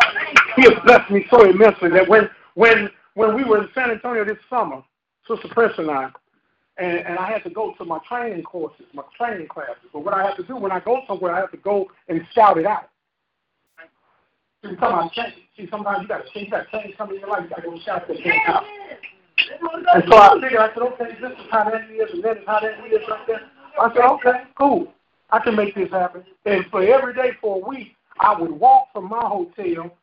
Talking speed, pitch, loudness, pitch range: 230 wpm, 220 Hz, -18 LUFS, 195-245 Hz